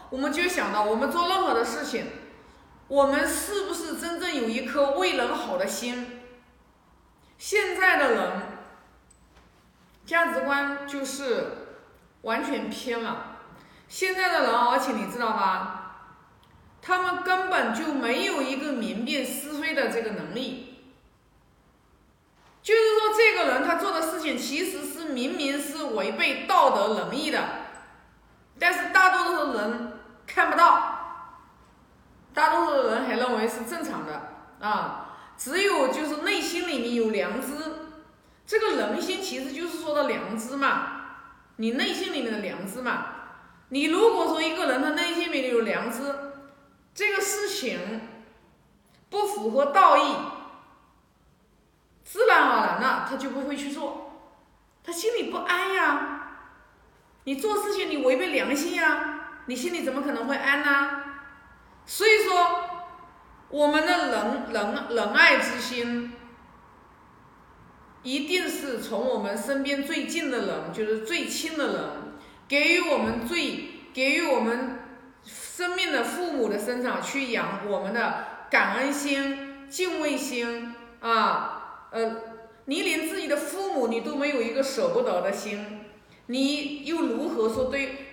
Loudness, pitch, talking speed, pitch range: -25 LUFS, 280 Hz, 200 characters per minute, 245-345 Hz